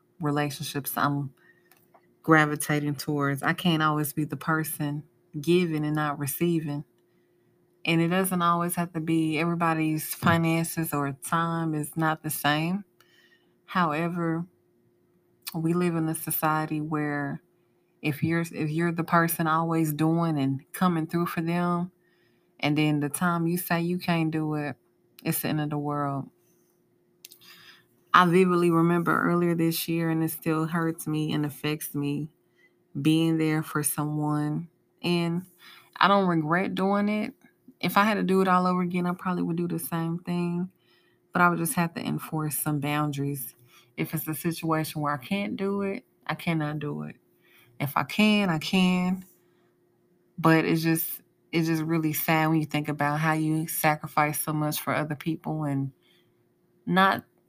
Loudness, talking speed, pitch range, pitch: -26 LUFS, 160 wpm, 150-175 Hz, 160 Hz